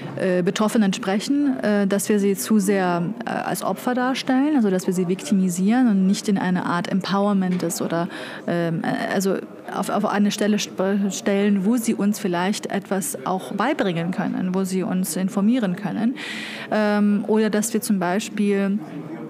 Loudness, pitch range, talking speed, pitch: -22 LUFS, 190-220 Hz, 145 wpm, 200 Hz